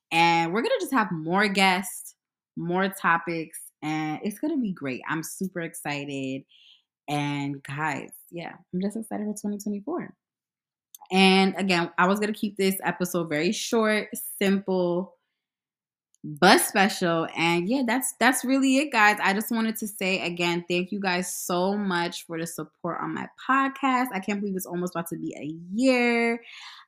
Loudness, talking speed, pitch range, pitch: -25 LUFS, 160 wpm, 170-210 Hz, 185 Hz